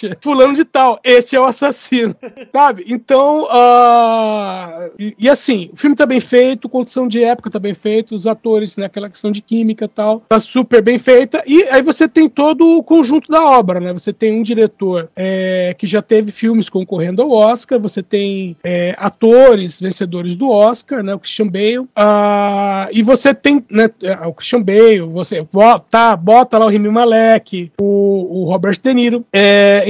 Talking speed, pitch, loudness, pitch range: 185 wpm, 220 Hz, -12 LUFS, 200-250 Hz